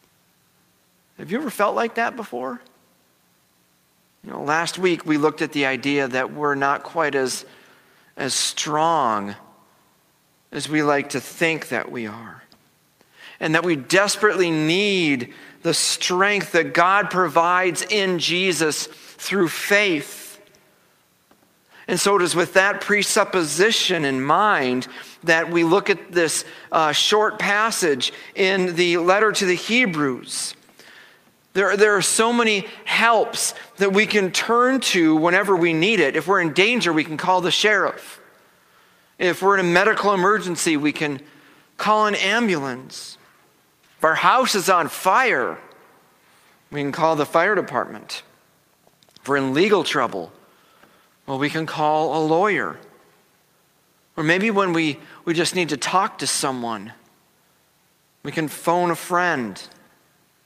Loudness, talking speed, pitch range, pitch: -19 LUFS, 140 wpm, 150-195 Hz, 170 Hz